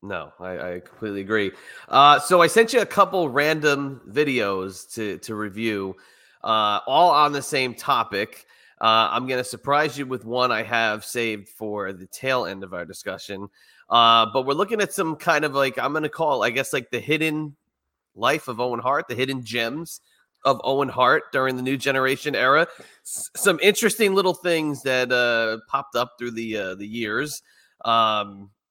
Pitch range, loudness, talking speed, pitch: 110-150 Hz, -22 LUFS, 185 wpm, 125 Hz